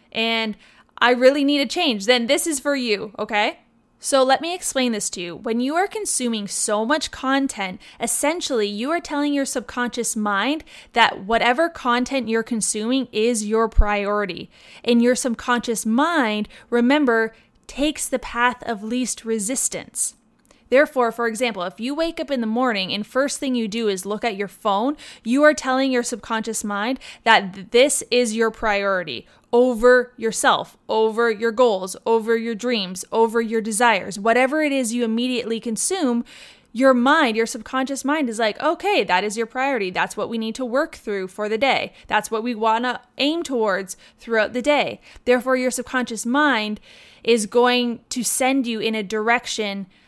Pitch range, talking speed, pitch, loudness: 225-265 Hz, 170 wpm, 240 Hz, -21 LUFS